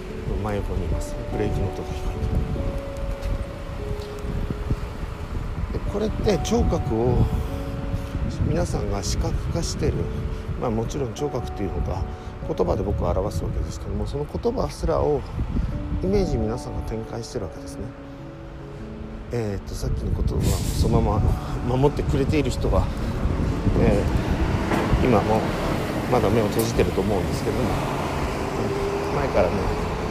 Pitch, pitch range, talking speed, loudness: 95 Hz, 85-110 Hz, 275 characters per minute, -25 LUFS